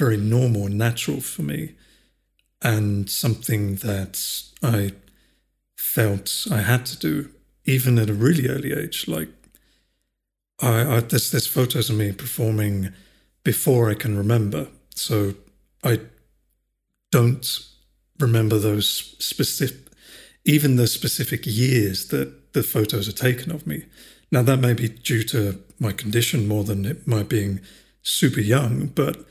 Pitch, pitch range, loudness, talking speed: 115 Hz, 100-125 Hz, -22 LUFS, 135 wpm